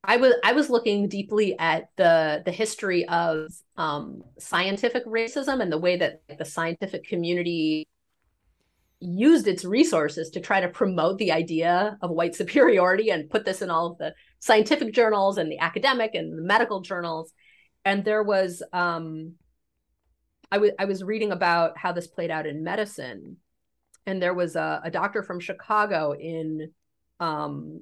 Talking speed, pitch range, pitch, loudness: 160 wpm, 160-205 Hz, 175 Hz, -24 LUFS